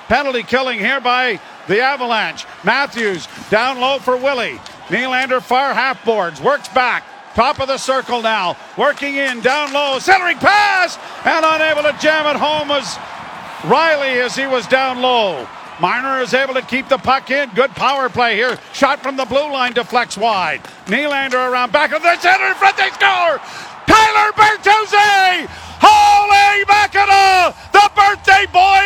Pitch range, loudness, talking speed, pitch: 255-370 Hz, -14 LUFS, 160 wpm, 275 Hz